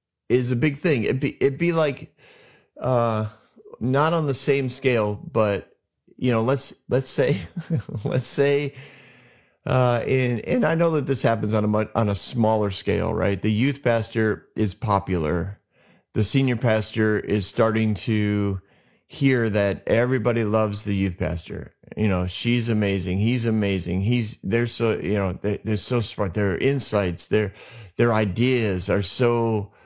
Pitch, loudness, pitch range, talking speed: 115 Hz, -23 LUFS, 105-130 Hz, 160 wpm